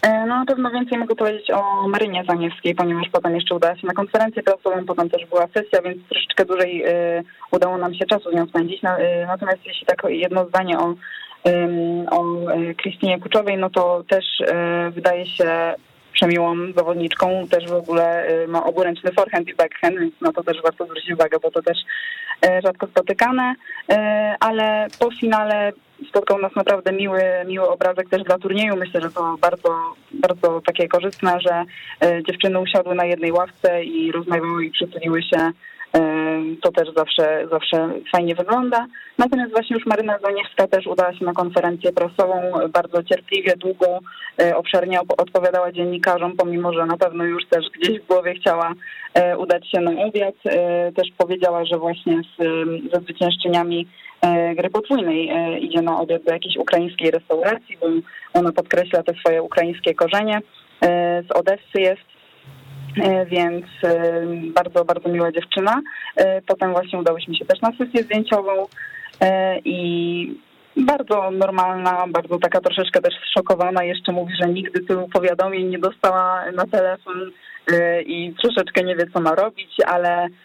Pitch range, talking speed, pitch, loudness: 170-195 Hz, 150 wpm, 180 Hz, -20 LUFS